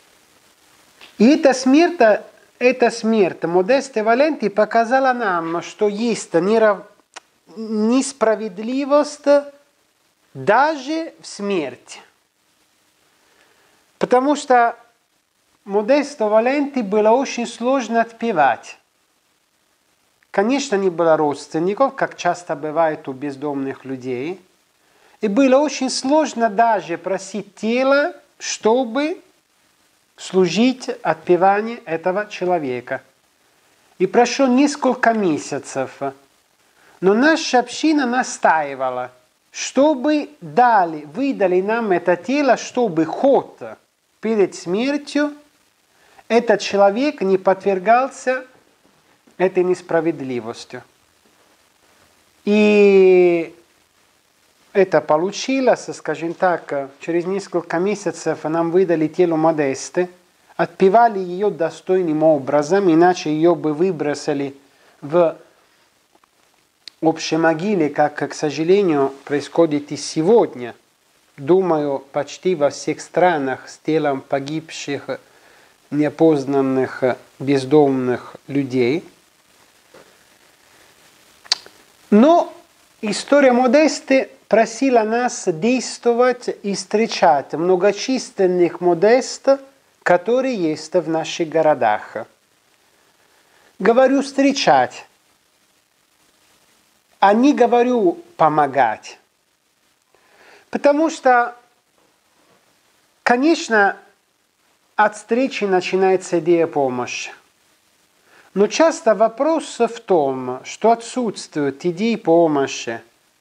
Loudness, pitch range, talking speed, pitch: -18 LUFS, 160-245 Hz, 80 wpm, 200 Hz